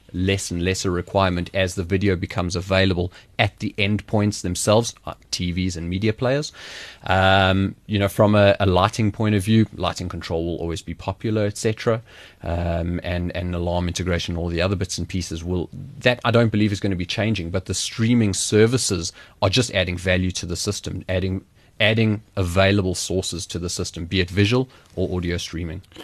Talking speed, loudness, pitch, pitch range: 180 wpm, -22 LUFS, 95 Hz, 90-105 Hz